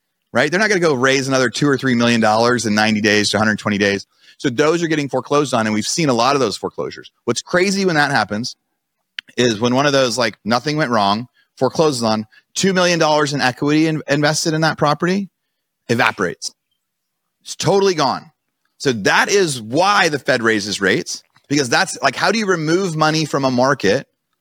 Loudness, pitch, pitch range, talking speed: -16 LUFS, 140 Hz, 115-155 Hz, 200 wpm